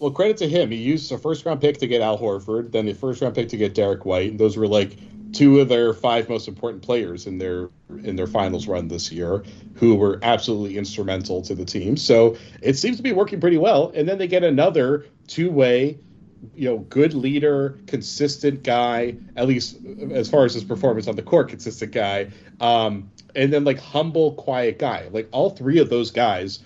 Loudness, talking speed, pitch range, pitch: -21 LUFS, 215 wpm, 105-145 Hz, 120 Hz